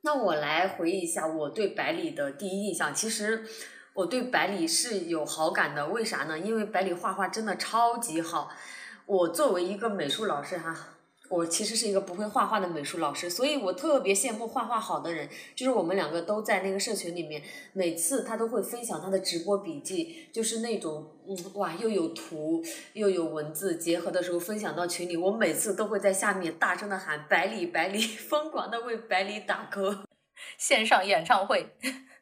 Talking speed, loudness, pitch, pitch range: 300 characters per minute, -29 LUFS, 200 Hz, 180-230 Hz